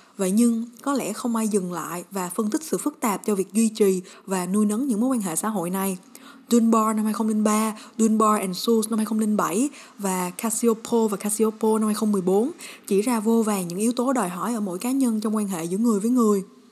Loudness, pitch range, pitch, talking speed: -23 LUFS, 200-235 Hz, 220 Hz, 225 wpm